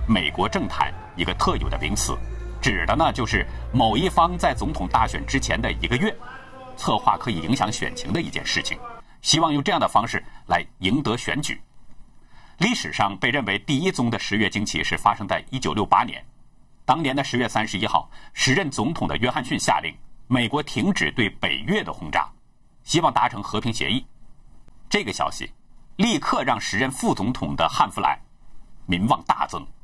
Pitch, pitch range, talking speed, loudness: 125 Hz, 105-165 Hz, 275 characters per minute, -23 LUFS